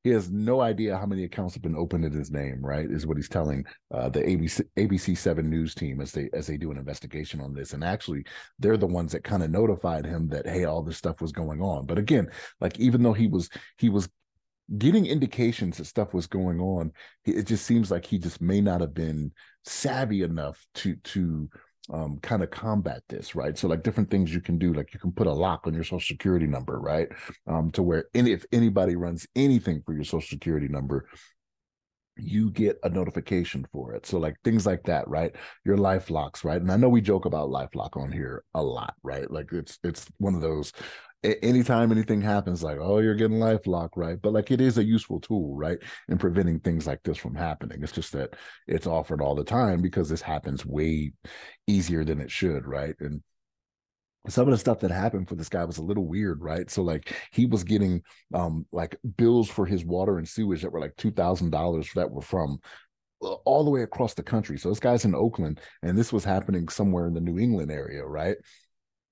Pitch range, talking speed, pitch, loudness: 80-105 Hz, 220 wpm, 90 Hz, -27 LUFS